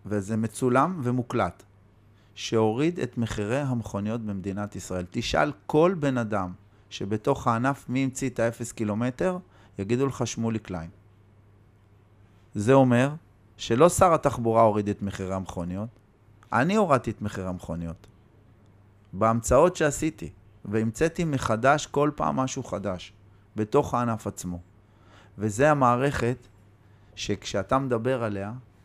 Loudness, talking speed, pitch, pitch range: -26 LUFS, 110 wpm, 110 Hz, 100-125 Hz